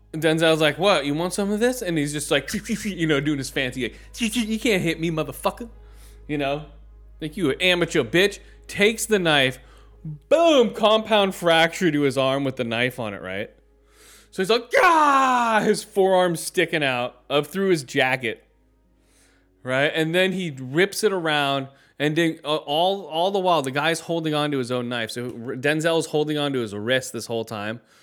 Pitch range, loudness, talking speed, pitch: 130-190 Hz, -22 LUFS, 185 wpm, 155 Hz